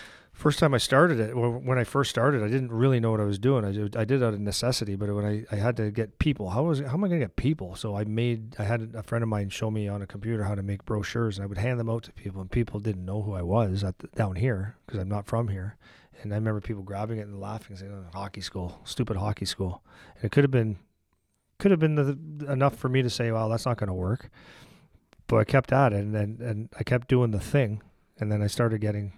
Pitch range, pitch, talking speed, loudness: 100-125 Hz, 110 Hz, 280 wpm, -27 LUFS